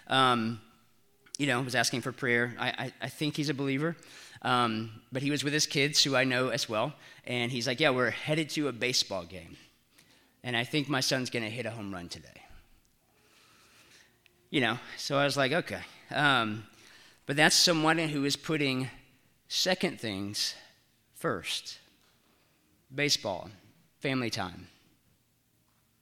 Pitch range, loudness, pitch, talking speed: 115-145 Hz, -29 LUFS, 130 Hz, 155 wpm